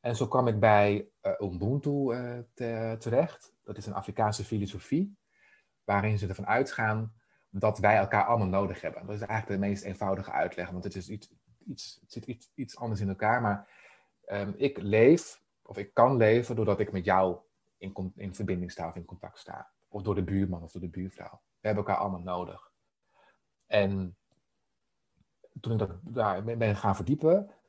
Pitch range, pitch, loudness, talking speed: 95-115 Hz, 105 Hz, -29 LUFS, 180 wpm